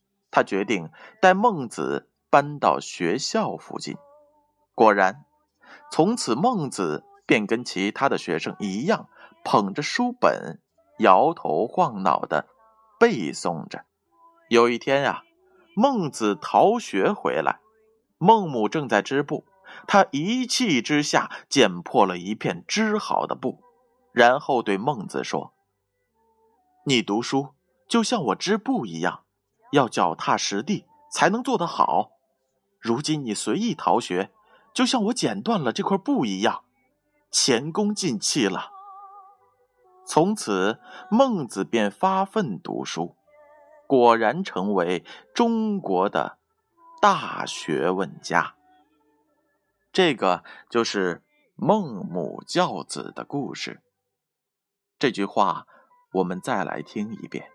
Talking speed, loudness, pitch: 165 characters per minute, -23 LUFS, 200 Hz